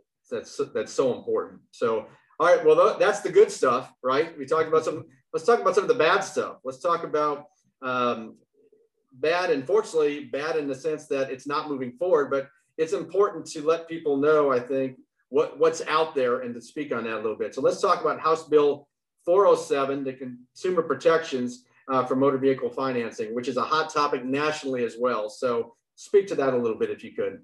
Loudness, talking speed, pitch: -25 LUFS, 205 wpm, 160 Hz